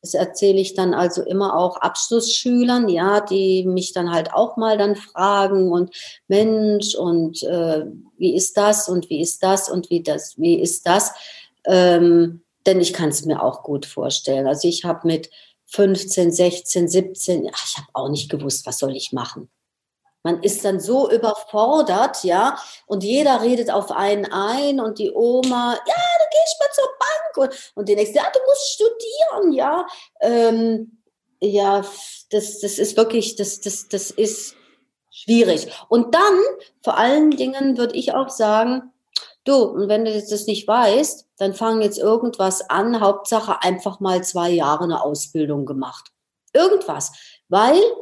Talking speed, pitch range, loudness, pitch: 165 wpm, 180-245 Hz, -19 LUFS, 205 Hz